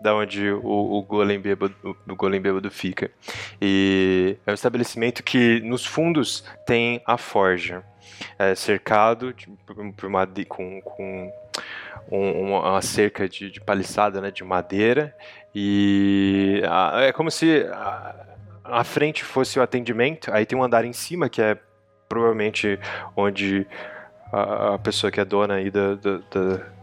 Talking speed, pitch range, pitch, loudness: 150 wpm, 100-115 Hz, 100 Hz, -22 LUFS